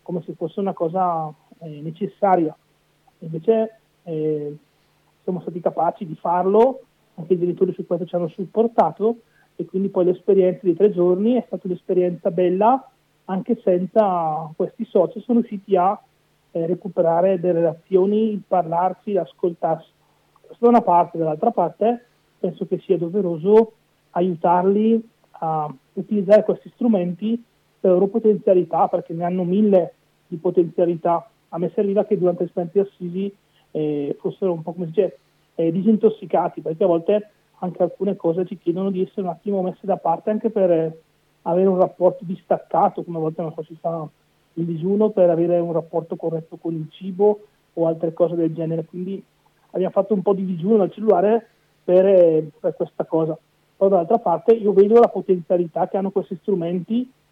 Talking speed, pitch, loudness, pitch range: 165 wpm, 180 Hz, -20 LUFS, 170-200 Hz